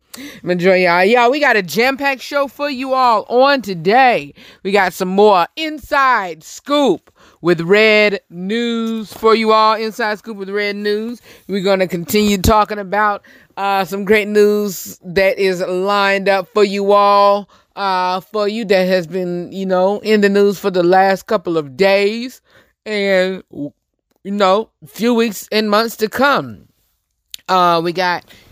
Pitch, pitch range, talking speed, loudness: 200 Hz, 185-220 Hz, 160 wpm, -15 LUFS